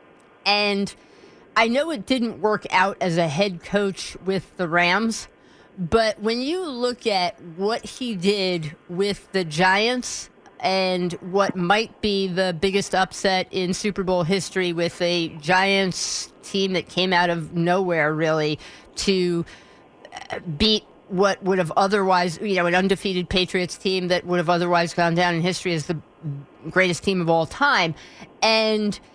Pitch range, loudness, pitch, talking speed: 175-200 Hz, -22 LUFS, 185 Hz, 150 wpm